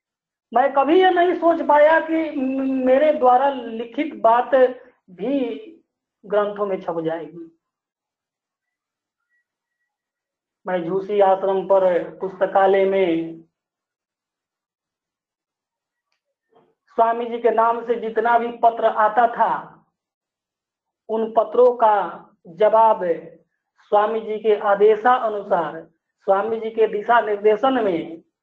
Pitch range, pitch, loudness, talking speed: 195-255 Hz, 225 Hz, -19 LUFS, 100 wpm